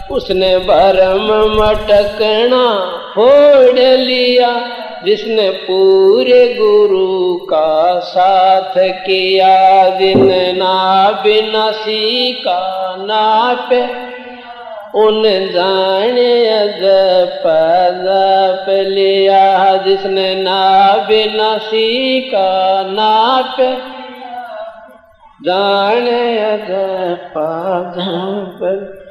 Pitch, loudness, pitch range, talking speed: 200 Hz, -11 LUFS, 190-240 Hz, 60 wpm